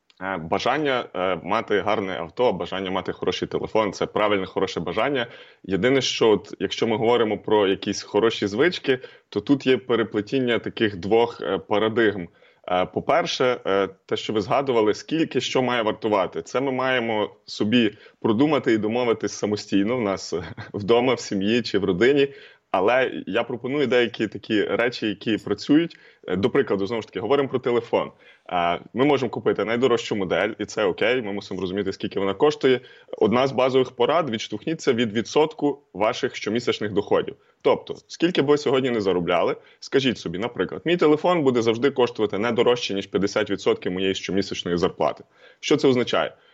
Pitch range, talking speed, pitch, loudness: 100-135 Hz, 155 wpm, 120 Hz, -23 LUFS